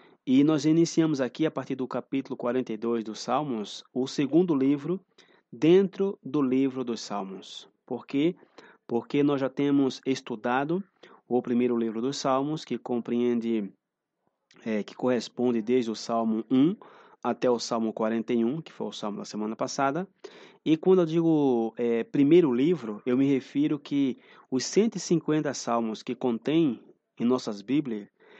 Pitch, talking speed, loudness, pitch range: 130 Hz, 150 wpm, -27 LUFS, 120-155 Hz